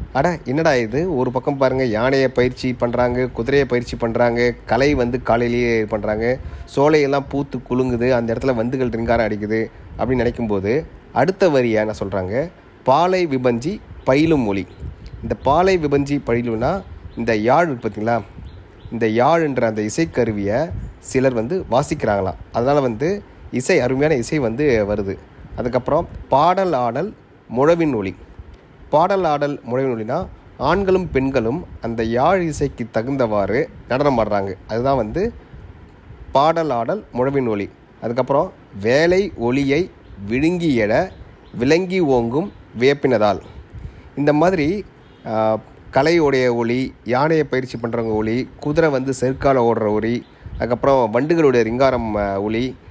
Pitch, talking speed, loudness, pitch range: 120 Hz, 115 wpm, -19 LUFS, 110-140 Hz